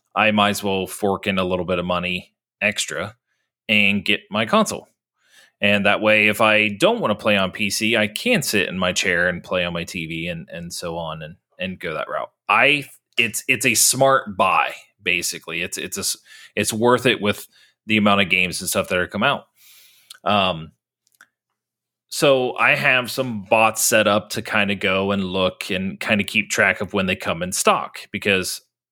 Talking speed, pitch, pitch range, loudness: 200 wpm, 105 Hz, 95-110 Hz, -19 LUFS